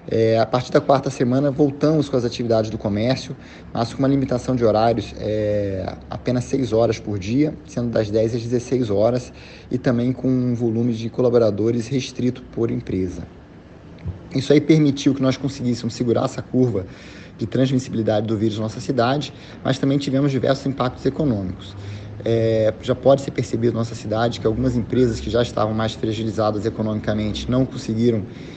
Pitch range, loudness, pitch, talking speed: 110-130 Hz, -21 LUFS, 120 Hz, 170 wpm